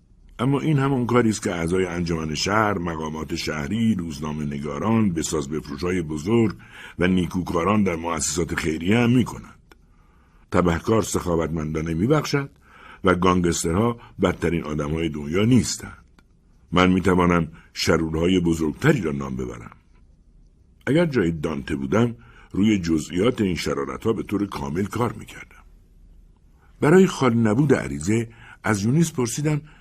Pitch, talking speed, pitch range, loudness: 90 Hz, 130 wpm, 80-110 Hz, -22 LUFS